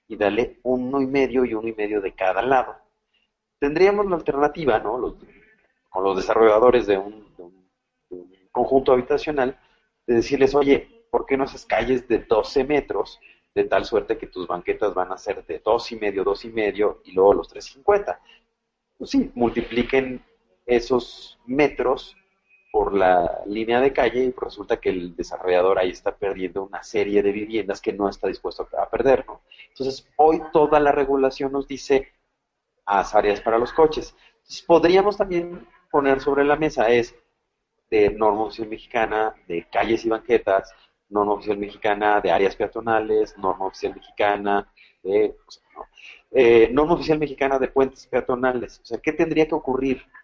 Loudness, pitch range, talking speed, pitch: -22 LUFS, 105-160 Hz, 170 wpm, 130 Hz